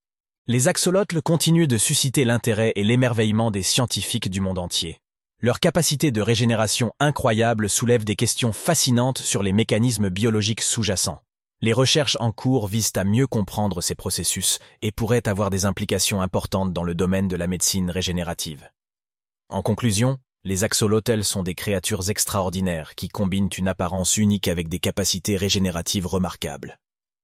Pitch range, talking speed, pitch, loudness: 95-120 Hz, 150 wpm, 105 Hz, -22 LUFS